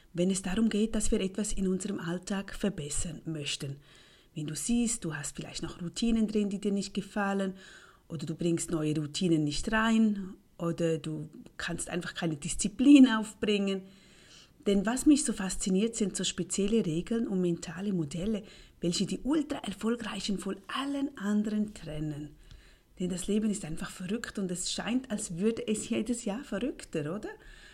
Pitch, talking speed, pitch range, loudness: 195 Hz, 160 wpm, 170-220 Hz, -31 LUFS